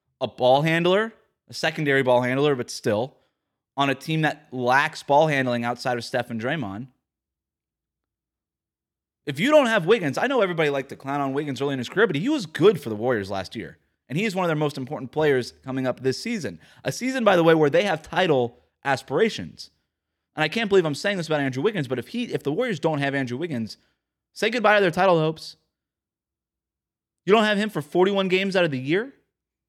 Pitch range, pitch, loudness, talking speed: 125-180 Hz, 145 Hz, -23 LUFS, 215 wpm